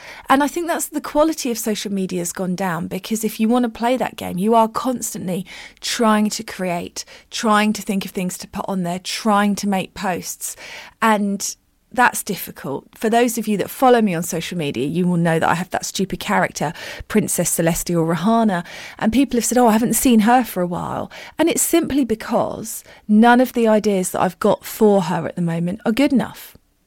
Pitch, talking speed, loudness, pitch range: 215 Hz, 215 wpm, -19 LUFS, 185-235 Hz